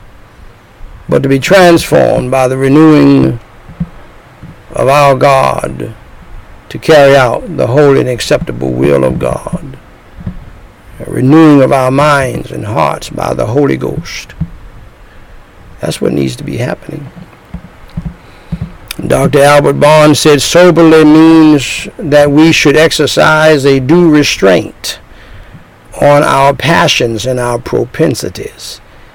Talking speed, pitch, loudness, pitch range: 115 wpm, 145 Hz, -7 LUFS, 130-155 Hz